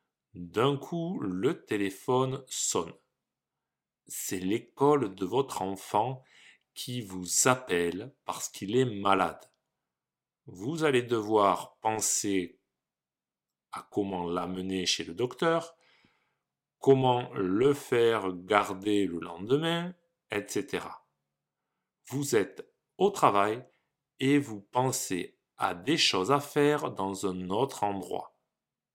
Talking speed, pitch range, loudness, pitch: 105 wpm, 95-135 Hz, -29 LUFS, 110 Hz